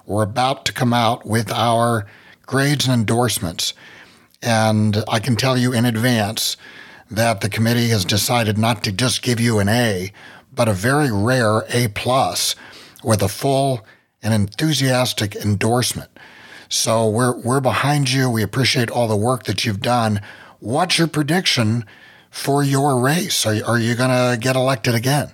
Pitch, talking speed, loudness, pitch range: 120 Hz, 160 wpm, -18 LUFS, 110-130 Hz